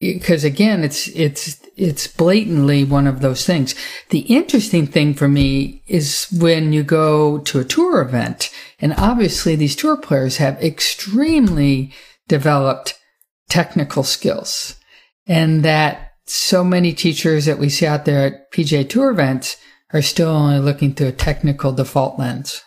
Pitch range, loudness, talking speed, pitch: 140-175 Hz, -16 LUFS, 150 wpm, 155 Hz